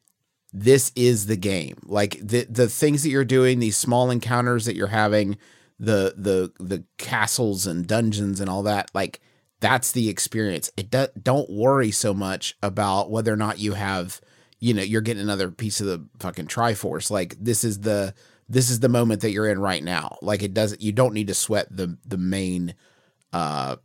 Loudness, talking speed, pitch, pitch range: -23 LUFS, 195 wpm, 105 Hz, 100-120 Hz